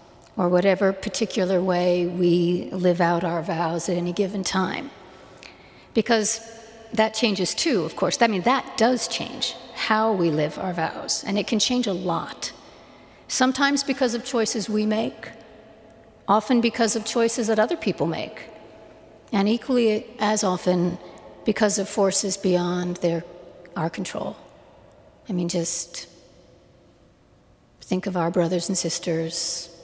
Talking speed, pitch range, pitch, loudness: 140 wpm, 175-225 Hz, 195 Hz, -23 LUFS